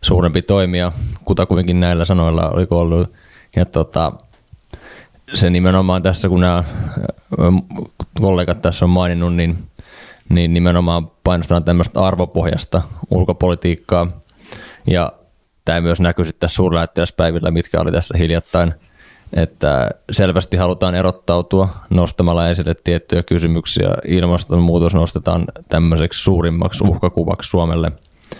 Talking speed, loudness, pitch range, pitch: 110 wpm, -16 LUFS, 85-90 Hz, 85 Hz